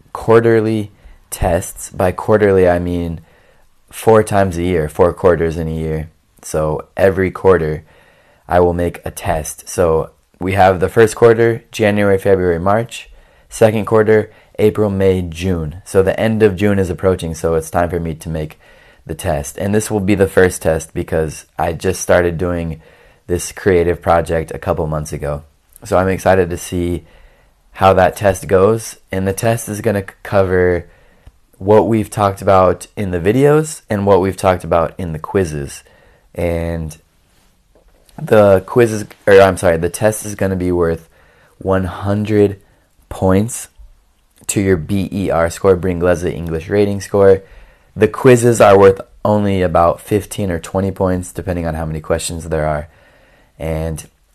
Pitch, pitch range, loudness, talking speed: 95 Hz, 85-100 Hz, -15 LUFS, 160 wpm